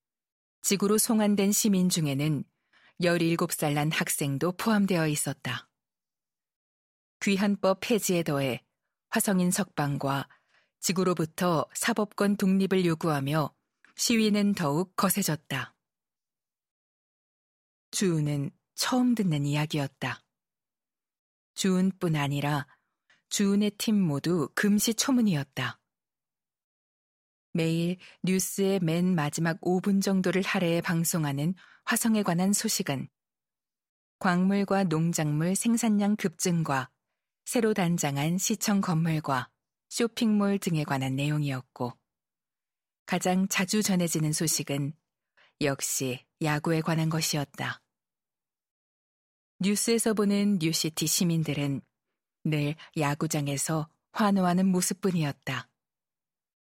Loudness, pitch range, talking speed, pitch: -27 LUFS, 150-200 Hz, 215 characters per minute, 175 Hz